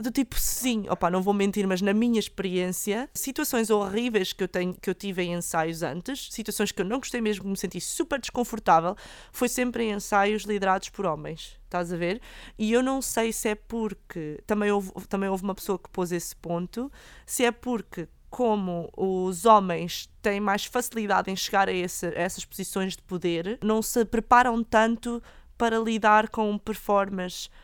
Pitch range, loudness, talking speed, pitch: 185-230 Hz, -27 LUFS, 185 wpm, 205 Hz